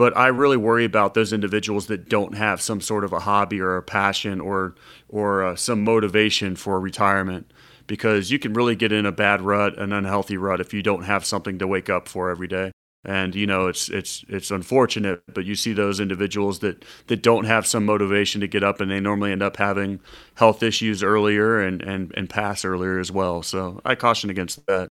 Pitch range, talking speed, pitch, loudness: 95-105 Hz, 215 wpm, 100 Hz, -22 LUFS